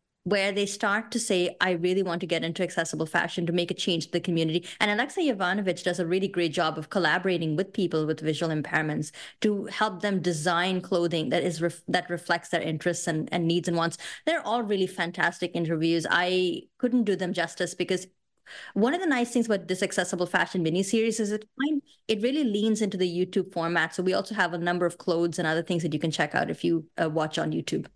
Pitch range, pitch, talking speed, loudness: 170-200 Hz, 180 Hz, 225 wpm, -27 LUFS